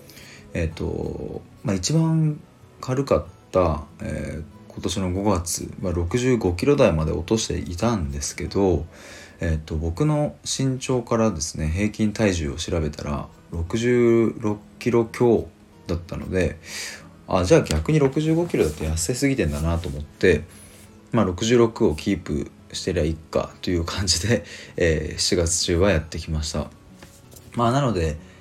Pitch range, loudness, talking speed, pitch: 80-115 Hz, -23 LUFS, 260 characters per minute, 95 Hz